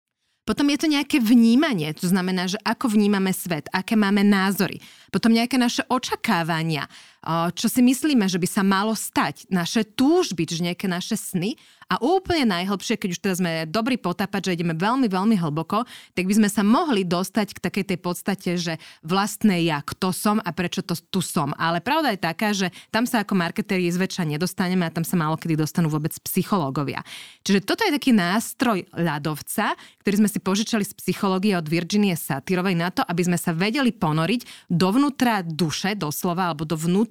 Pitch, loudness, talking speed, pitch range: 190 Hz, -22 LUFS, 180 wpm, 175-220 Hz